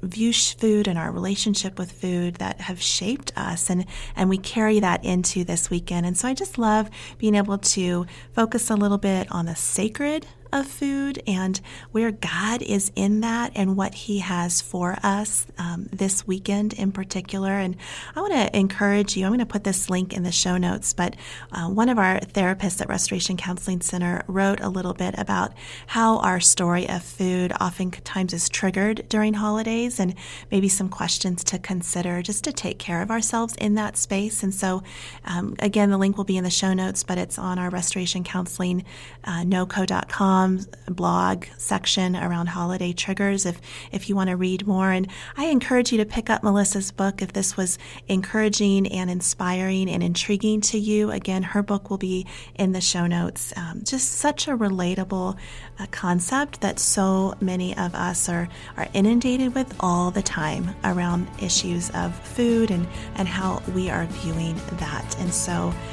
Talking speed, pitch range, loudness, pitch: 185 wpm, 180-210 Hz, -23 LUFS, 190 Hz